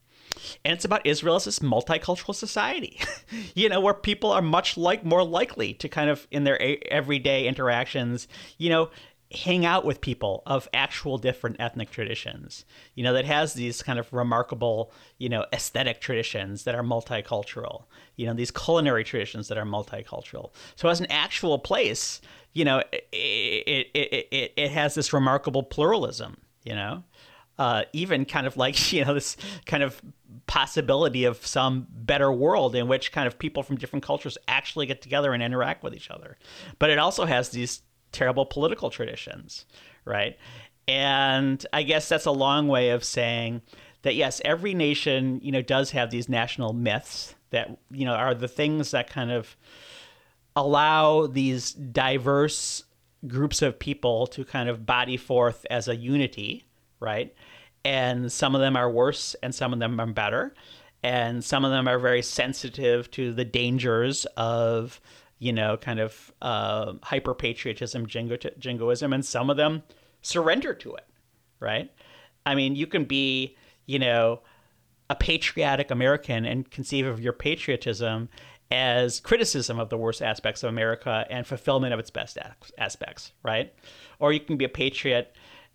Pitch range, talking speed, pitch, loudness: 120-145 Hz, 165 wpm, 130 Hz, -26 LUFS